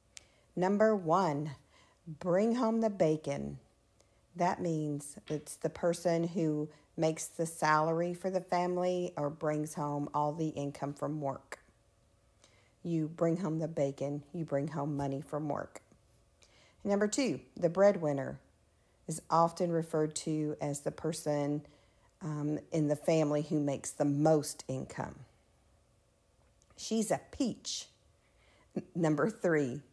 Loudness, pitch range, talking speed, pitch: -33 LUFS, 140-170 Hz, 125 wpm, 150 Hz